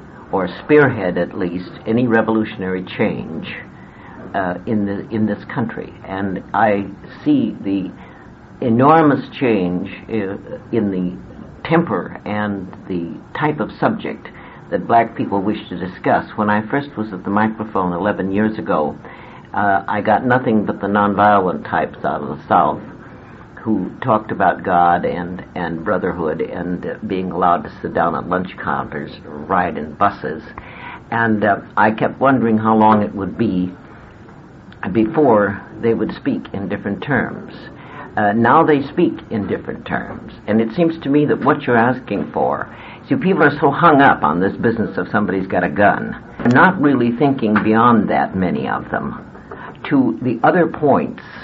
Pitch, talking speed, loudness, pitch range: 105 Hz, 160 wpm, -17 LUFS, 95-115 Hz